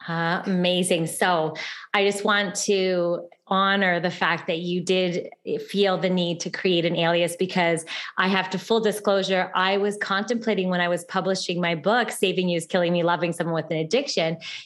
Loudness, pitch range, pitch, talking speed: -23 LUFS, 175-195 Hz, 185 Hz, 185 wpm